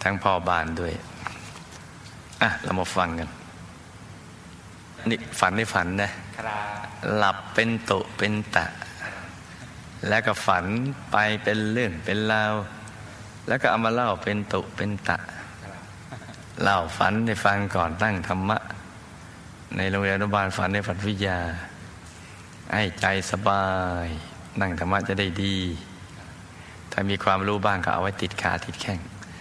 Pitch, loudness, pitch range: 100 Hz, -25 LUFS, 90-105 Hz